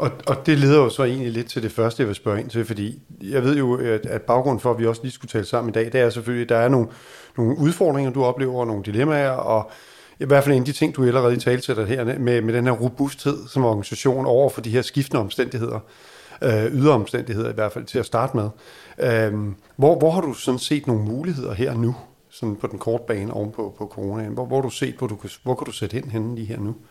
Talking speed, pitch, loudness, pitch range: 250 wpm, 120 Hz, -22 LUFS, 110-135 Hz